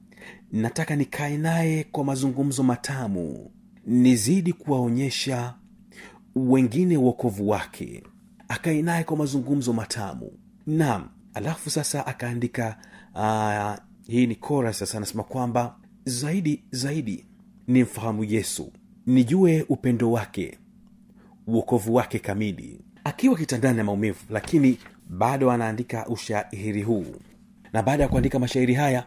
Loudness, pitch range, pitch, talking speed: -25 LUFS, 115-160 Hz, 130 Hz, 110 wpm